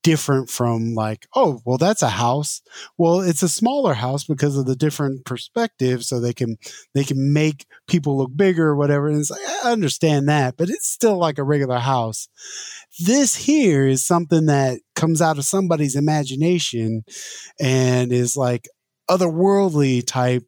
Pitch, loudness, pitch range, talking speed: 145 Hz, -19 LUFS, 130-170 Hz, 165 wpm